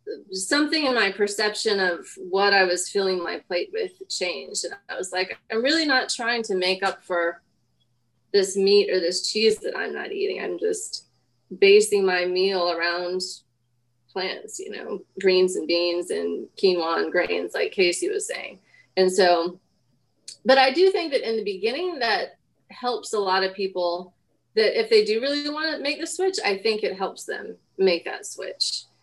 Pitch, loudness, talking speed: 210 Hz, -23 LUFS, 180 wpm